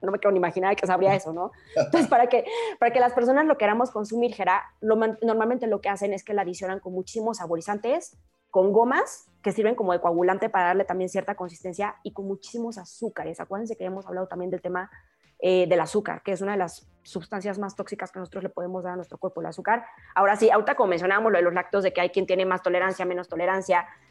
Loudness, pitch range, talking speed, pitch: -25 LUFS, 180-220 Hz, 235 wpm, 195 Hz